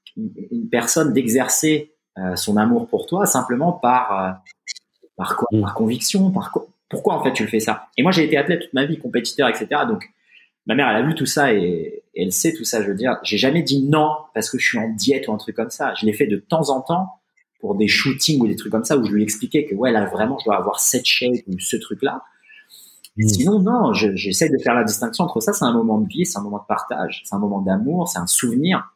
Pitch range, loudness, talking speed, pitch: 110-180 Hz, -19 LUFS, 255 wpm, 130 Hz